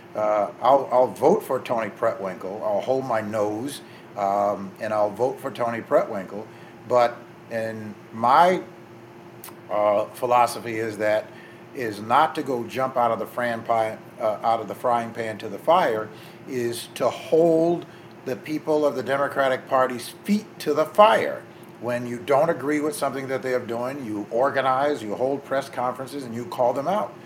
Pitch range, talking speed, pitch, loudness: 110-135 Hz, 170 wpm, 120 Hz, -24 LUFS